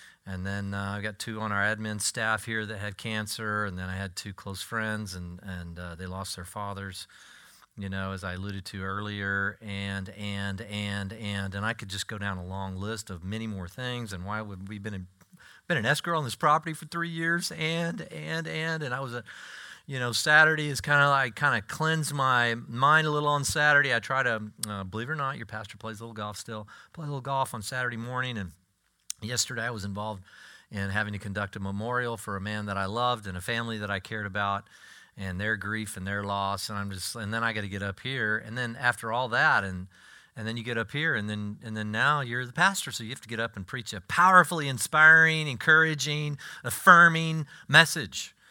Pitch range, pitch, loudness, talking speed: 100-135 Hz, 110 Hz, -27 LUFS, 230 wpm